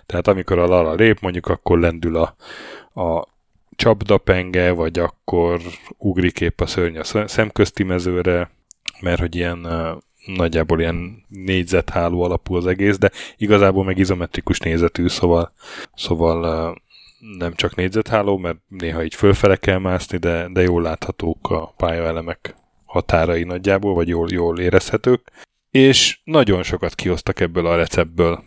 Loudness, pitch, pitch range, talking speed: -18 LUFS, 90 Hz, 85-95 Hz, 135 wpm